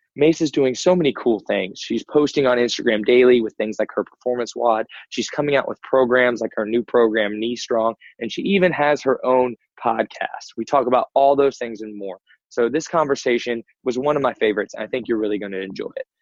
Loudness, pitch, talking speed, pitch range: -20 LUFS, 125 Hz, 225 wpm, 115-140 Hz